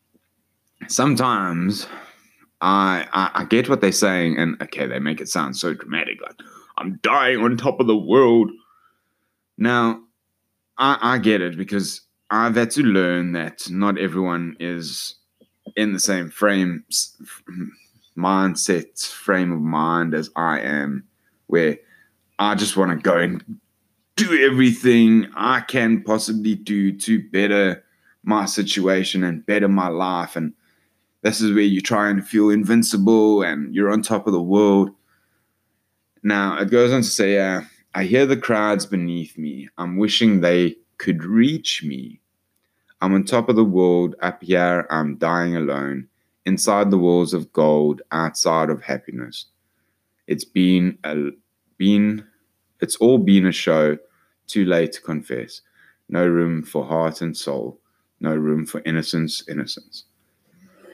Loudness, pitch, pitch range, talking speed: -19 LUFS, 100 Hz, 85-110 Hz, 145 wpm